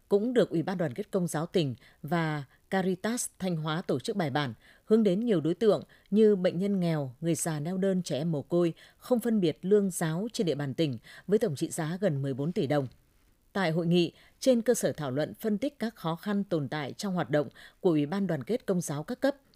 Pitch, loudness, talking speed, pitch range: 175 Hz, -29 LUFS, 235 wpm, 155-205 Hz